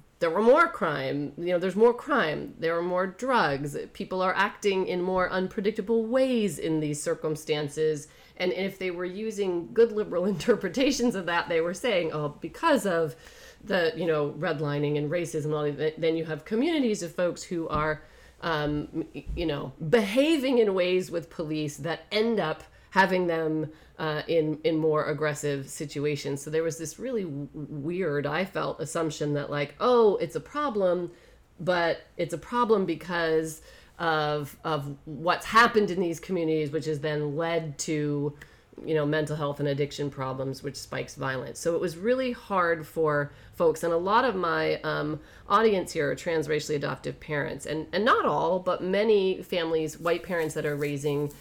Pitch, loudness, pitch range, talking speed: 165 Hz, -27 LUFS, 150-185 Hz, 170 wpm